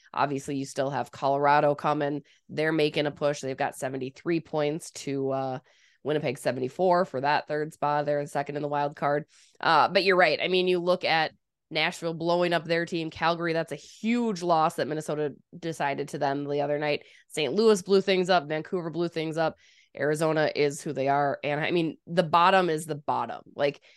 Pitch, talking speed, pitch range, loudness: 150 Hz, 200 wpm, 145-170 Hz, -27 LUFS